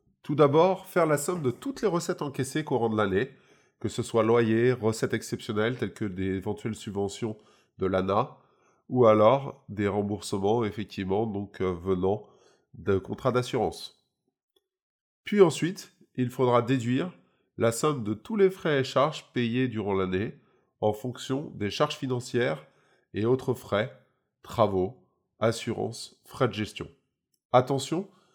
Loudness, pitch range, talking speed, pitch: -28 LUFS, 105-140 Hz, 140 wpm, 120 Hz